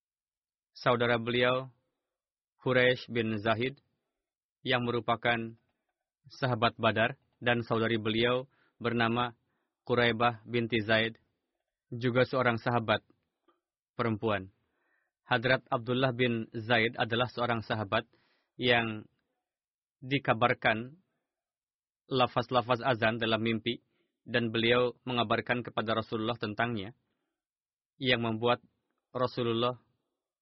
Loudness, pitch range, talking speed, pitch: -30 LUFS, 115-125 Hz, 85 wpm, 120 Hz